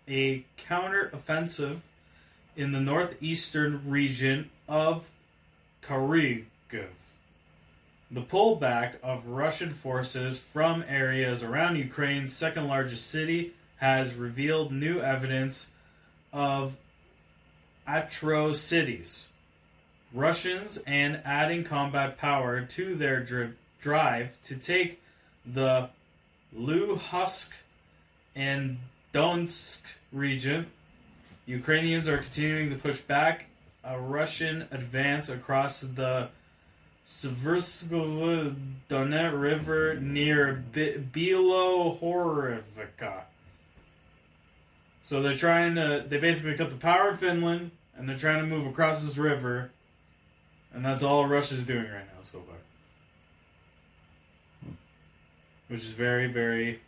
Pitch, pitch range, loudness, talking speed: 135 Hz, 115-155 Hz, -29 LUFS, 95 wpm